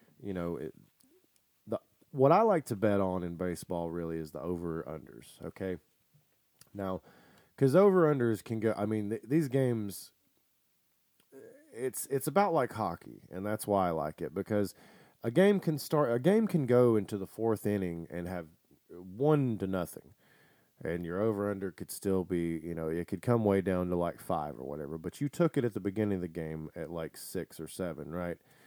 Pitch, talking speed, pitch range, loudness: 100 Hz, 195 wpm, 85-125 Hz, -32 LUFS